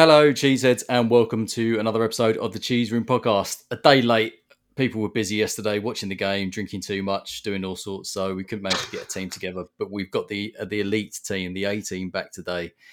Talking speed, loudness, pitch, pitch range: 230 wpm, -24 LUFS, 105 Hz, 95-115 Hz